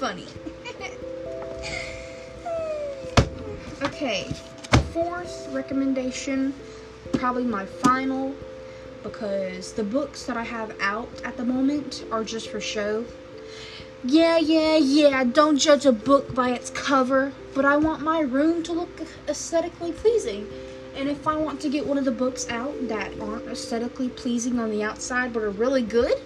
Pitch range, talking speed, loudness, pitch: 230-295 Hz, 140 wpm, -24 LUFS, 265 Hz